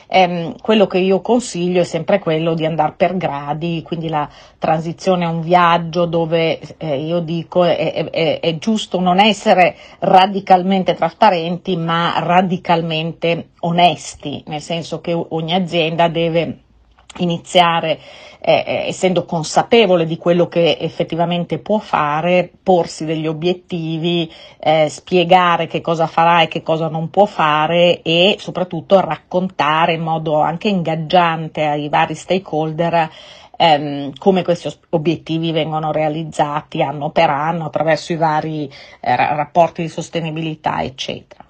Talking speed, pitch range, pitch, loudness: 125 wpm, 160-180 Hz, 170 Hz, -16 LUFS